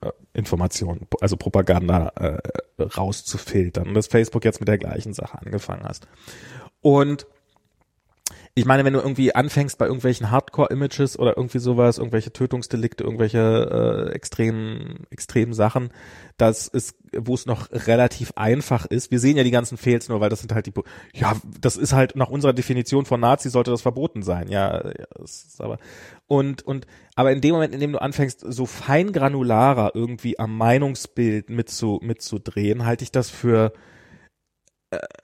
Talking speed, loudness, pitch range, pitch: 165 wpm, -22 LUFS, 110-135 Hz, 120 Hz